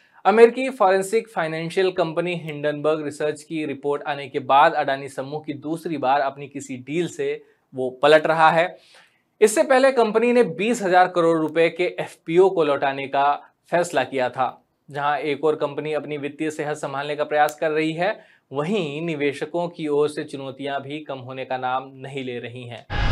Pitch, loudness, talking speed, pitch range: 150 Hz, -22 LUFS, 175 wpm, 140-170 Hz